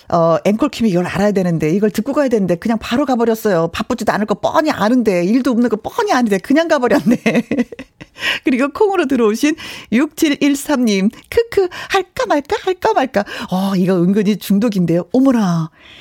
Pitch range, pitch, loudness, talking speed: 200-290 Hz, 240 Hz, -16 LUFS, 350 characters per minute